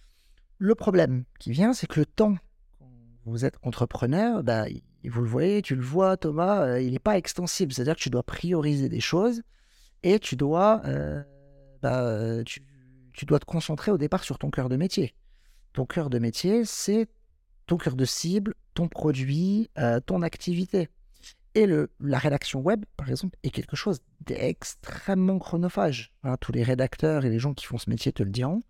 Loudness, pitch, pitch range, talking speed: -27 LUFS, 145 Hz, 125-185 Hz, 180 wpm